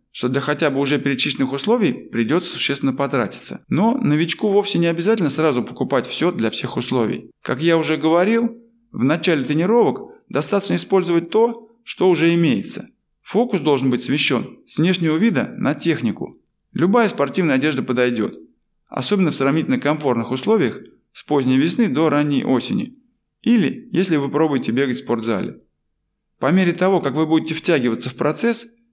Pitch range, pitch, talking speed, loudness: 140-210 Hz, 165 Hz, 155 wpm, -19 LUFS